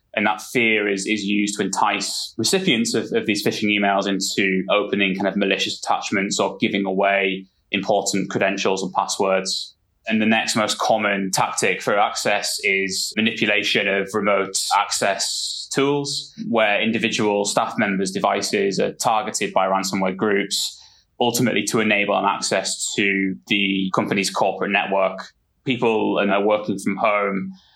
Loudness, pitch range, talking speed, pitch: -20 LUFS, 95-110 Hz, 145 wpm, 100 Hz